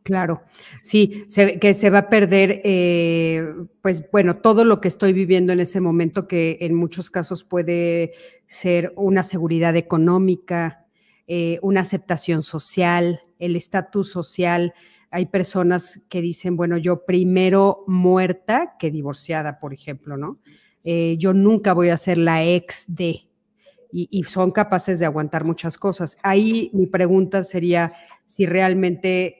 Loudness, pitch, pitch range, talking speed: -19 LUFS, 180 Hz, 170-190 Hz, 145 wpm